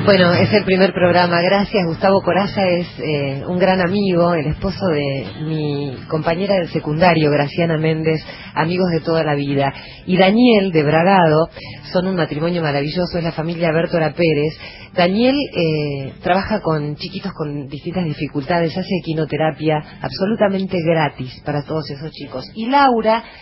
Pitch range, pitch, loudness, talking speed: 150-185 Hz, 165 Hz, -17 LUFS, 150 wpm